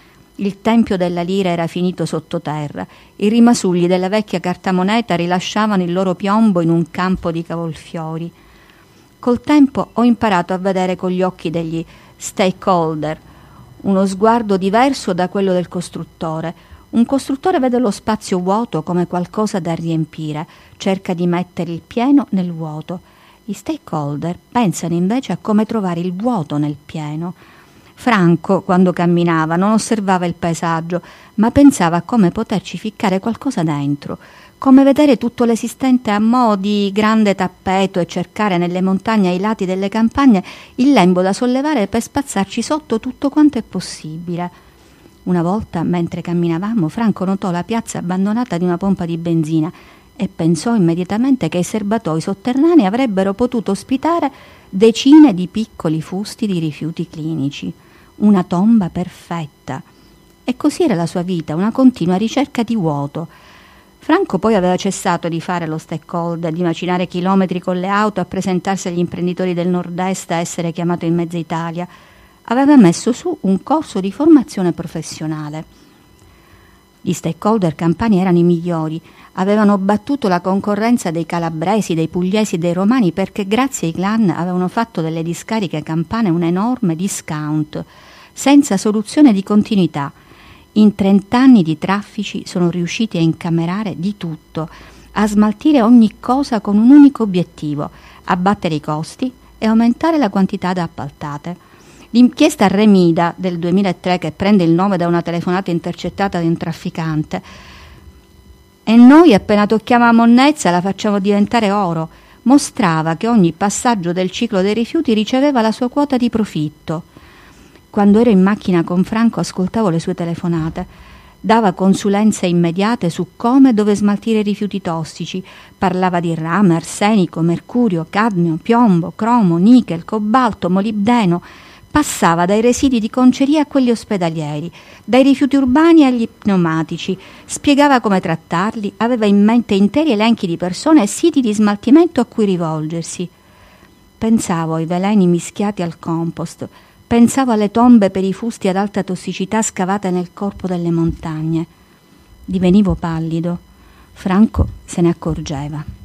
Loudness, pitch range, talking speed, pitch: -15 LUFS, 170-225 Hz, 145 wpm, 190 Hz